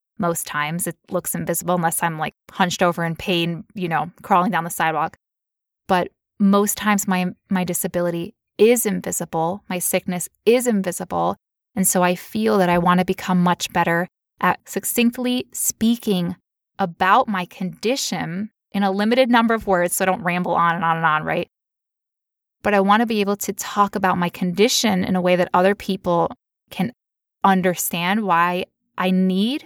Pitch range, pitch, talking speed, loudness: 175-205 Hz, 185 Hz, 170 wpm, -20 LUFS